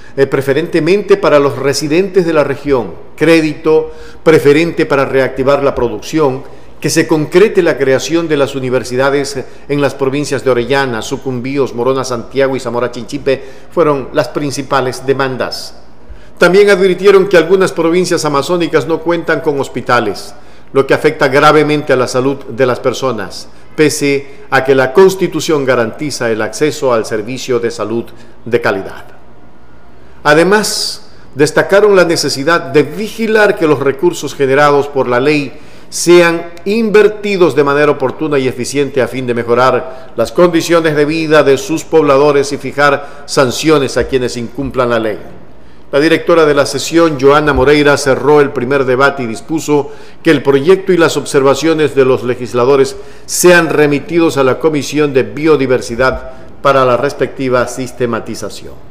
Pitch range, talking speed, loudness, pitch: 130-160 Hz, 145 wpm, -11 LUFS, 140 Hz